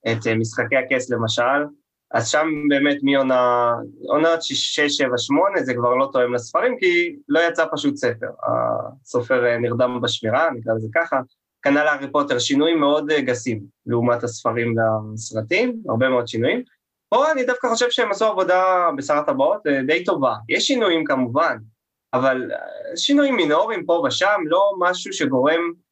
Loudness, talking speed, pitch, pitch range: -20 LUFS, 145 wpm, 140 Hz, 120-170 Hz